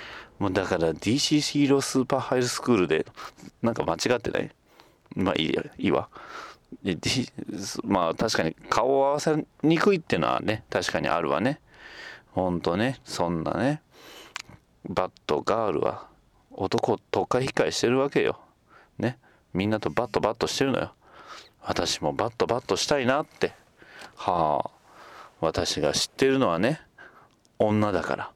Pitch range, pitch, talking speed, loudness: 95-145 Hz, 130 Hz, 295 characters per minute, -26 LUFS